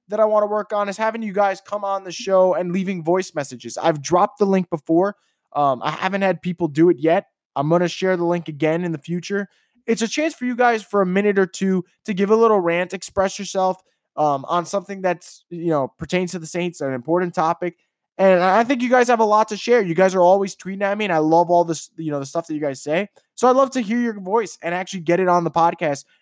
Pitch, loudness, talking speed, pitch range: 185 Hz, -20 LUFS, 265 wpm, 170-205 Hz